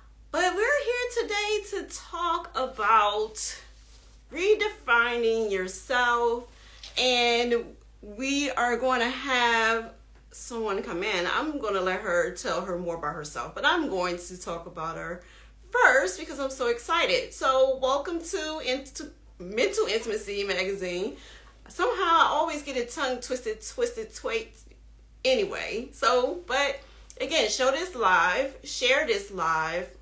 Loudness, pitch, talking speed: -26 LUFS, 260 Hz, 135 wpm